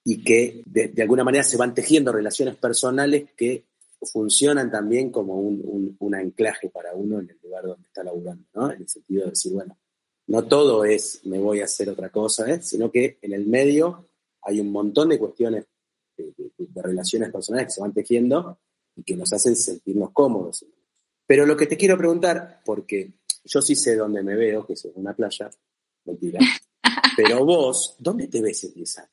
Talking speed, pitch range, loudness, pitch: 200 wpm, 100-150 Hz, -21 LUFS, 115 Hz